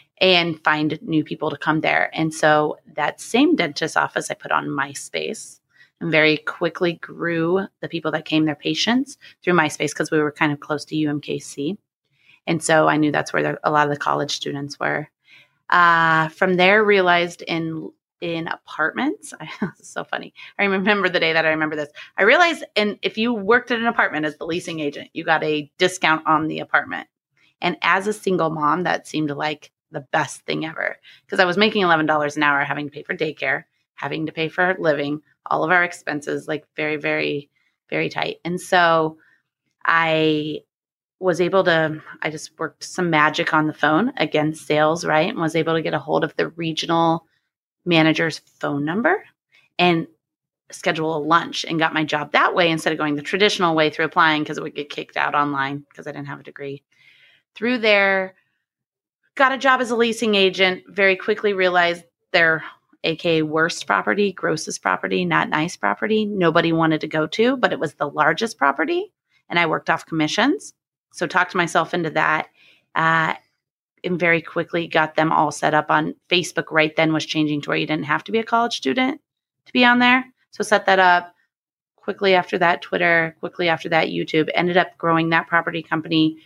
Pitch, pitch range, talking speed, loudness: 165 Hz, 155-180 Hz, 190 wpm, -20 LUFS